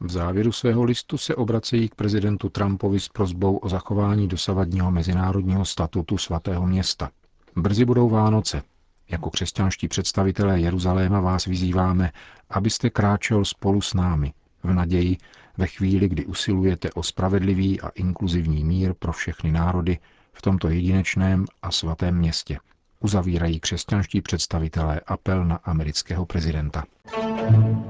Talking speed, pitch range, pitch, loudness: 125 wpm, 85-100 Hz, 95 Hz, -23 LUFS